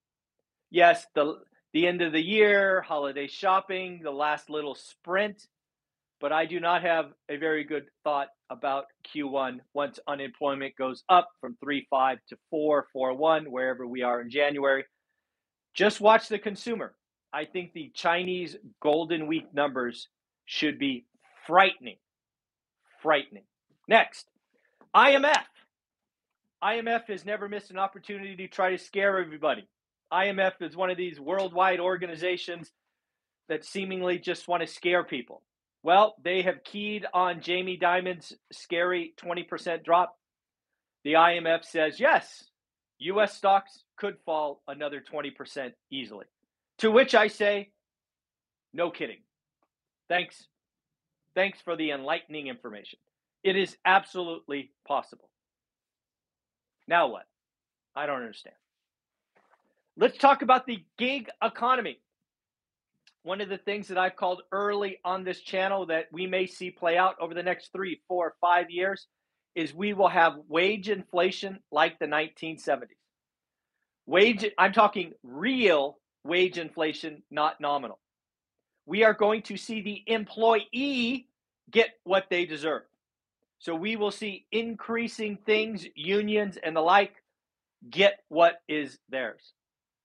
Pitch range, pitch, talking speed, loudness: 155-200 Hz, 180 Hz, 130 wpm, -27 LUFS